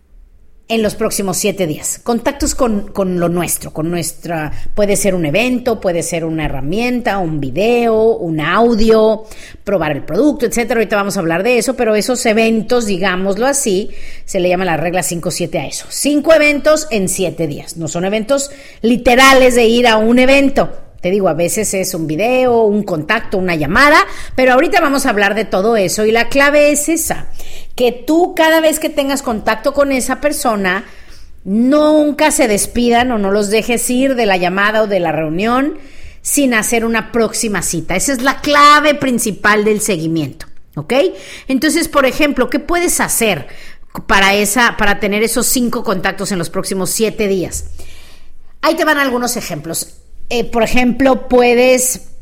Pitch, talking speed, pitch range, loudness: 220 Hz, 170 wpm, 185-255 Hz, -13 LUFS